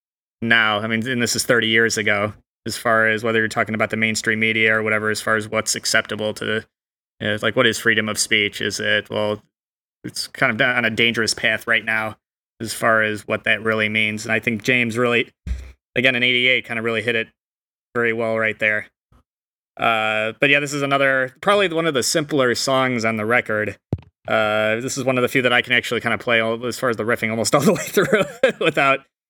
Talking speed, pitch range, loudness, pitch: 230 wpm, 110-125 Hz, -19 LUFS, 115 Hz